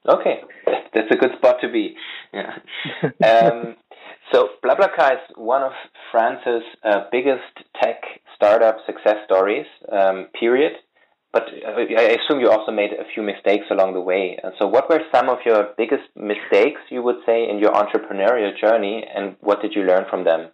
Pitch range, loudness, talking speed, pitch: 95-135 Hz, -19 LUFS, 170 wpm, 115 Hz